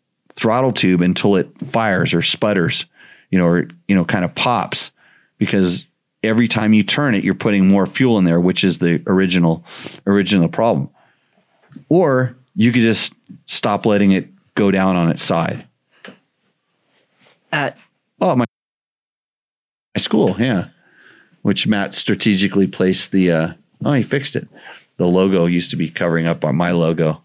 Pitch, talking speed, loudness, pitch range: 95 Hz, 155 wpm, -16 LUFS, 85-100 Hz